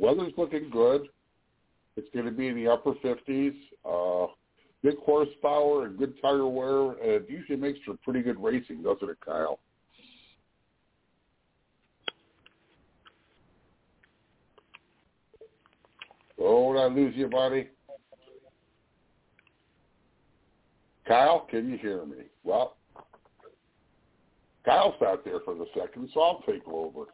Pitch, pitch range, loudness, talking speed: 140 Hz, 130-185 Hz, -28 LUFS, 110 wpm